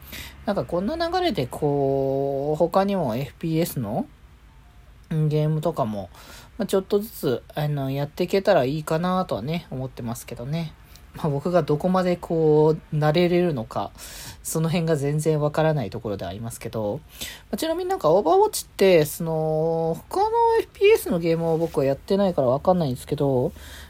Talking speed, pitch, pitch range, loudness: 340 characters per minute, 155 Hz, 135-180 Hz, -23 LUFS